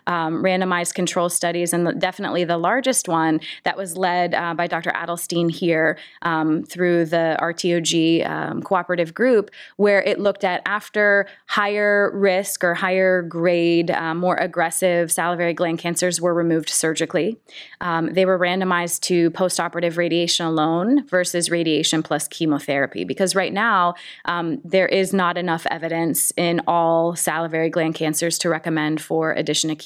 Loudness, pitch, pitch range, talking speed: -20 LUFS, 170 Hz, 165-185 Hz, 150 wpm